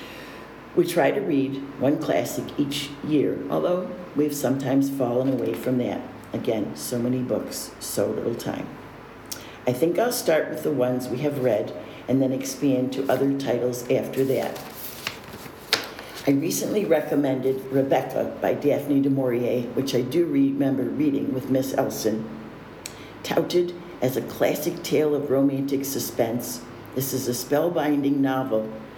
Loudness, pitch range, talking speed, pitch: -24 LUFS, 125-145 Hz, 145 wpm, 135 Hz